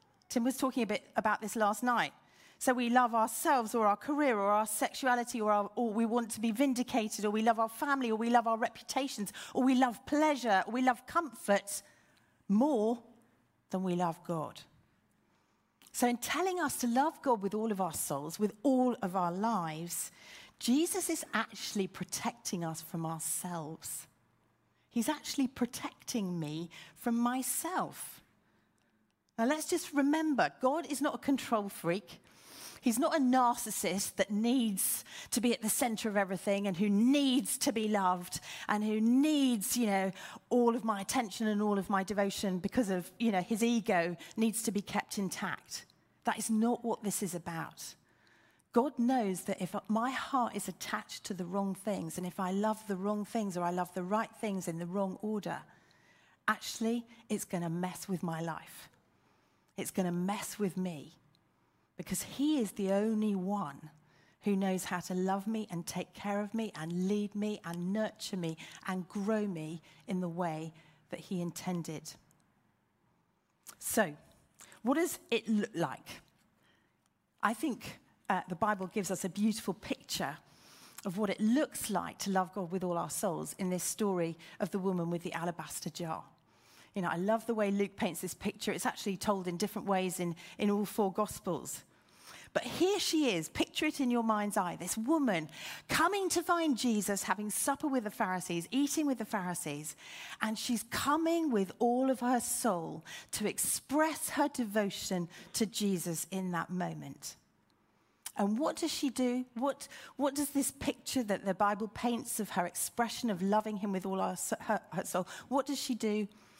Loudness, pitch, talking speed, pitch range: -34 LUFS, 210 Hz, 180 wpm, 185-245 Hz